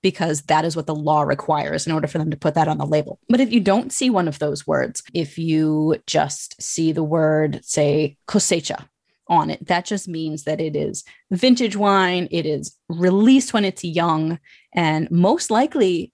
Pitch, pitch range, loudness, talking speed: 165 Hz, 155-195 Hz, -20 LUFS, 195 wpm